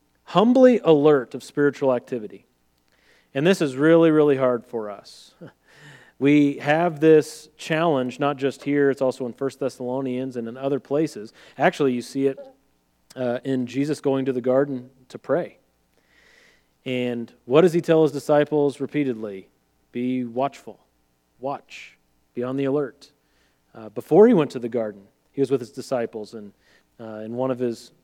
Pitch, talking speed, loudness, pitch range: 130 Hz, 160 wpm, -22 LUFS, 120-145 Hz